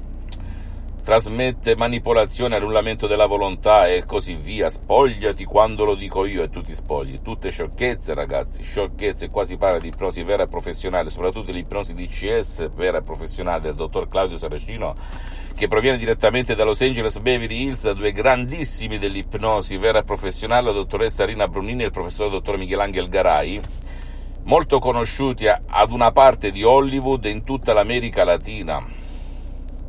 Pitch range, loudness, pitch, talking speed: 90-120 Hz, -20 LUFS, 105 Hz, 155 wpm